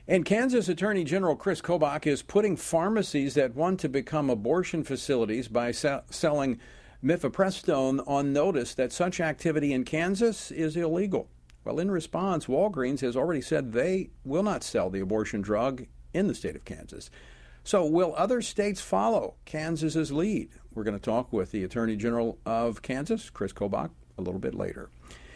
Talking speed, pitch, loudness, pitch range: 165 wpm, 150 Hz, -28 LUFS, 120-180 Hz